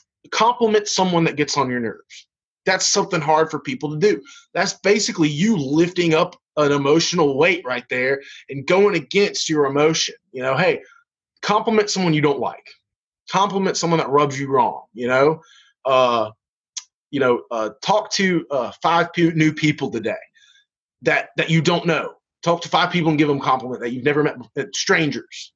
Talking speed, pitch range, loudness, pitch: 175 wpm, 140-190 Hz, -19 LUFS, 160 Hz